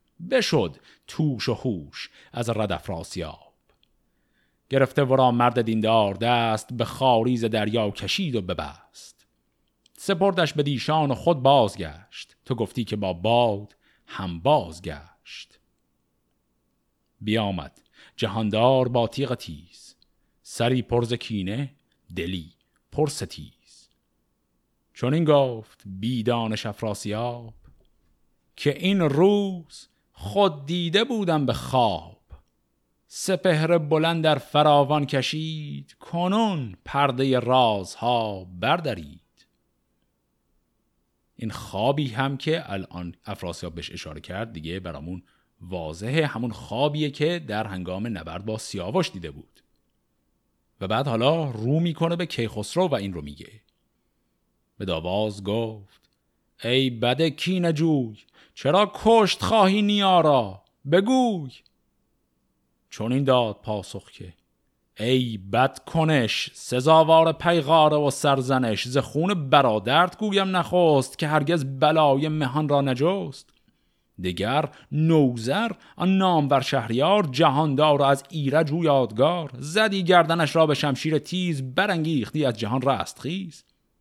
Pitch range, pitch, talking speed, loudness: 95-155 Hz, 125 Hz, 110 wpm, -23 LUFS